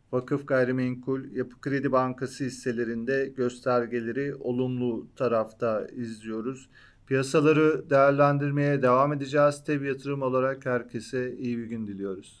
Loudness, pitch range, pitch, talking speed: -27 LUFS, 120-140 Hz, 130 Hz, 105 wpm